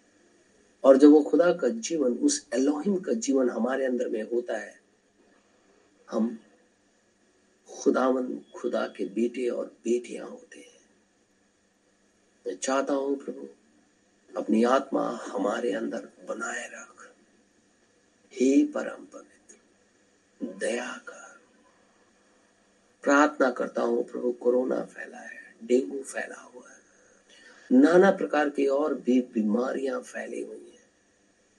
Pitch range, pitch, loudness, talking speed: 120-145 Hz, 130 Hz, -26 LUFS, 110 wpm